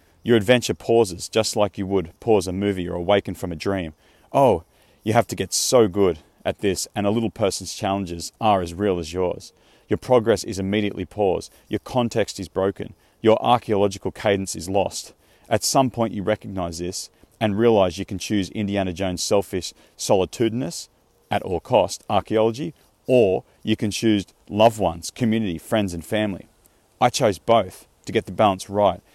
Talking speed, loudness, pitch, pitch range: 175 wpm, -22 LUFS, 100 Hz, 90-110 Hz